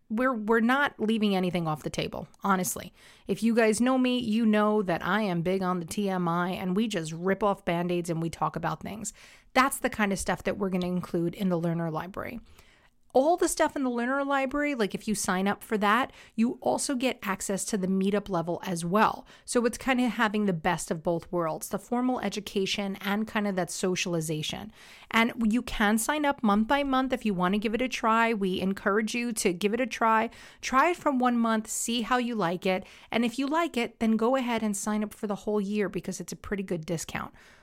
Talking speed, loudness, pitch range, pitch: 230 wpm, -28 LUFS, 185-235 Hz, 210 Hz